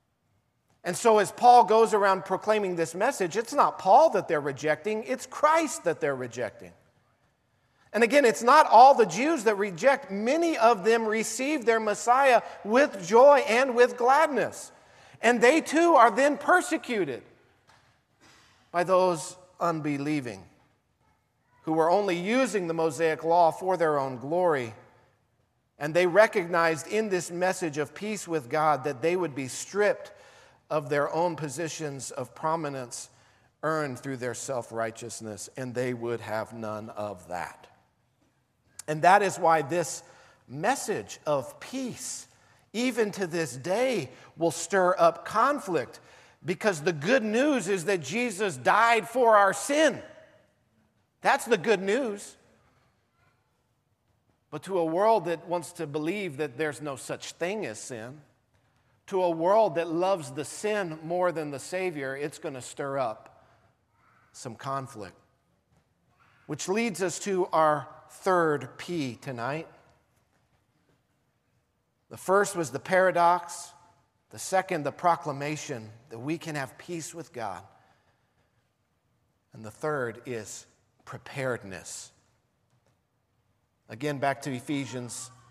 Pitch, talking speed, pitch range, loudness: 165 Hz, 135 wpm, 135-205 Hz, -26 LUFS